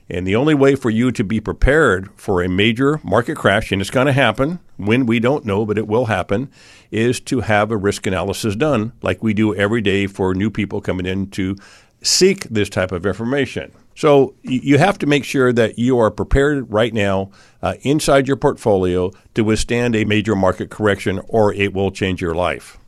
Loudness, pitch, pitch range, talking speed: -17 LUFS, 110 Hz, 100-125 Hz, 205 wpm